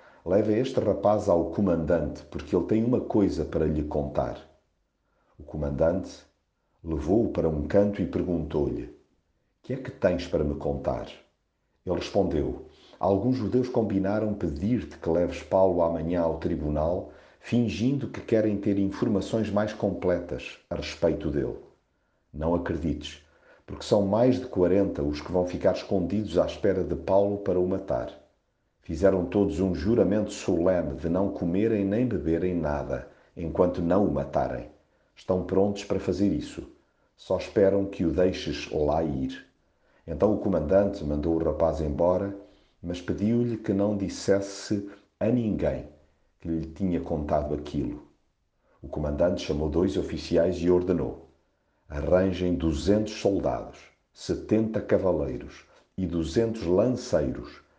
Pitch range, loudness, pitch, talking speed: 80-100 Hz, -27 LUFS, 90 Hz, 135 wpm